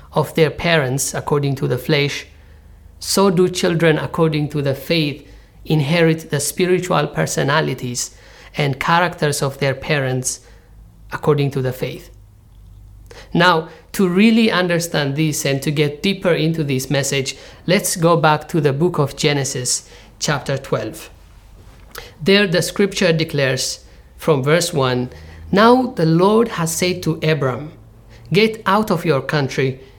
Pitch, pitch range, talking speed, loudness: 150 Hz, 130-170 Hz, 135 wpm, -17 LUFS